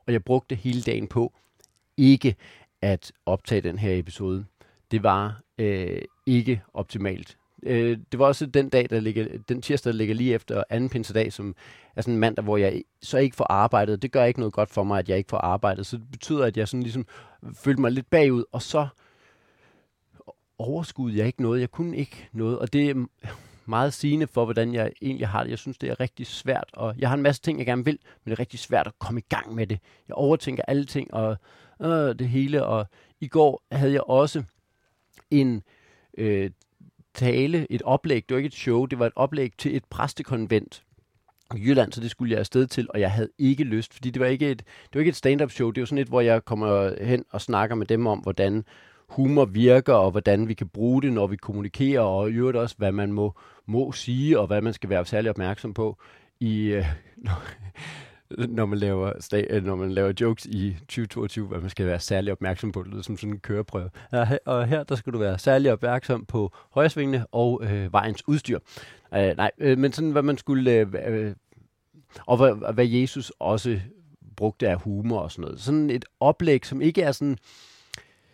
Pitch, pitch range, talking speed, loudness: 115 Hz, 105-130 Hz, 210 wpm, -25 LUFS